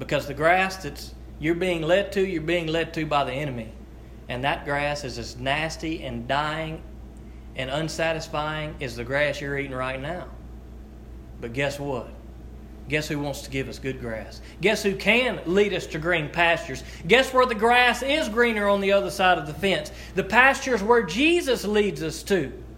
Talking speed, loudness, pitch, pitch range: 185 wpm, -24 LUFS, 160 Hz, 135-195 Hz